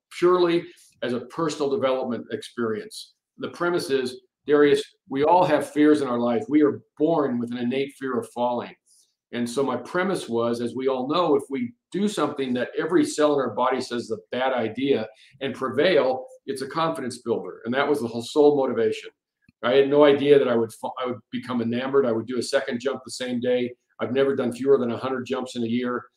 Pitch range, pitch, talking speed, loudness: 120-145 Hz, 130 Hz, 215 wpm, -24 LUFS